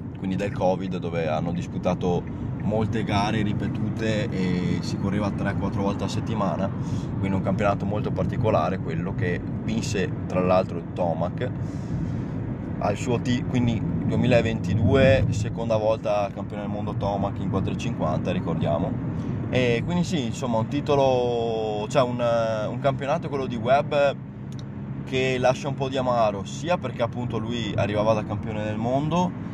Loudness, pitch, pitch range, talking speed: -25 LUFS, 110 Hz, 100-125 Hz, 140 wpm